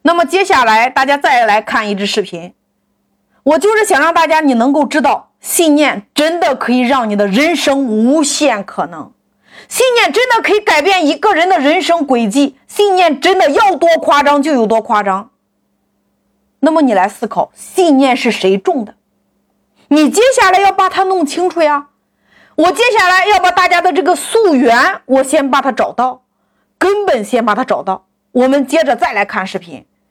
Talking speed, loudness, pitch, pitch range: 255 characters per minute, -11 LUFS, 295 Hz, 245-365 Hz